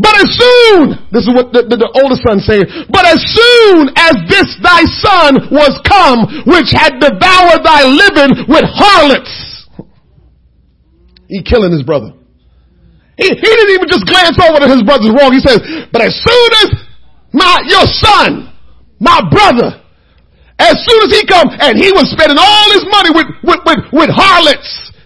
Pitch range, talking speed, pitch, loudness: 260-385 Hz, 170 wpm, 320 Hz, -6 LUFS